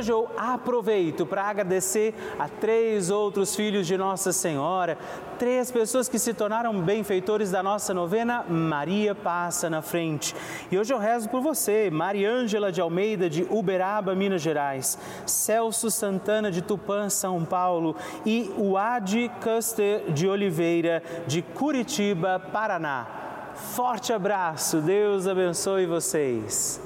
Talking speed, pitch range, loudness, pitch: 125 wpm, 180-220 Hz, -26 LUFS, 200 Hz